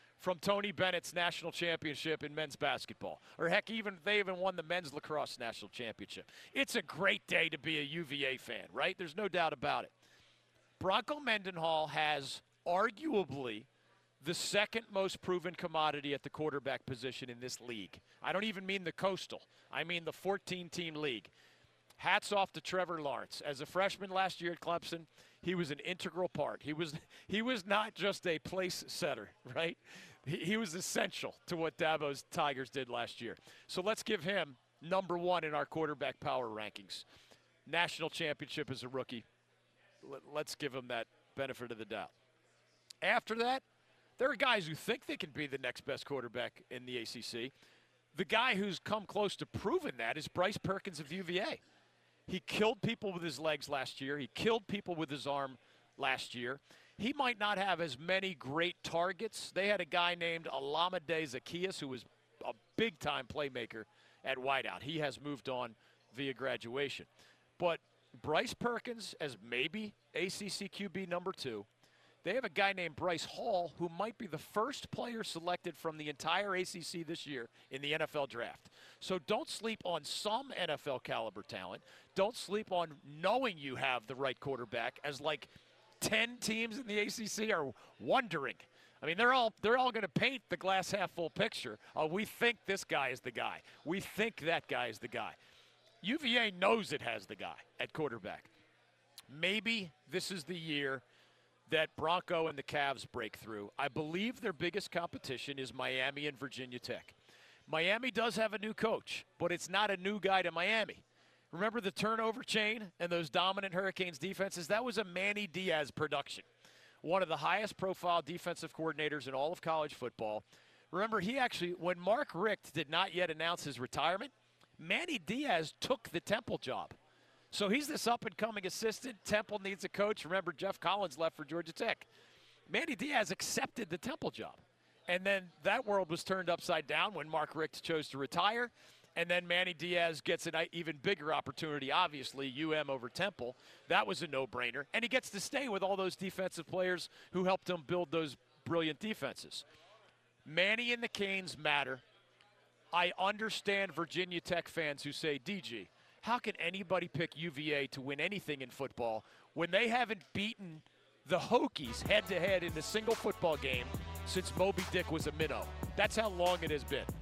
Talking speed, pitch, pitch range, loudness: 180 wpm, 175 Hz, 145-200 Hz, -37 LUFS